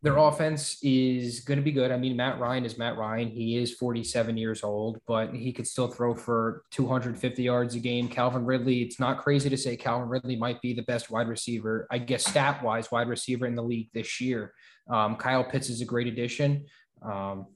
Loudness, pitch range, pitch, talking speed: -29 LUFS, 115-130 Hz, 120 Hz, 210 wpm